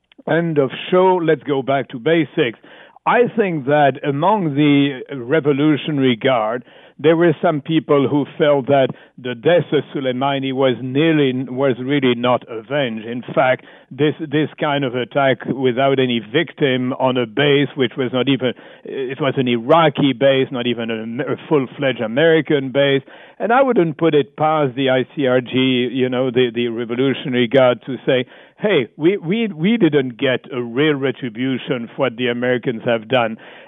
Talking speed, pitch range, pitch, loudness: 160 wpm, 125-150 Hz, 135 Hz, -17 LUFS